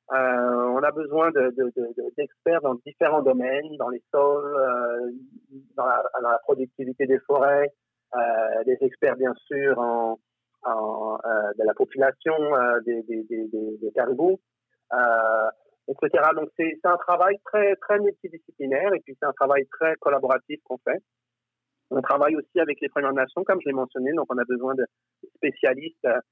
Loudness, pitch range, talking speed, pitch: -24 LUFS, 125-170 Hz, 165 wpm, 140 Hz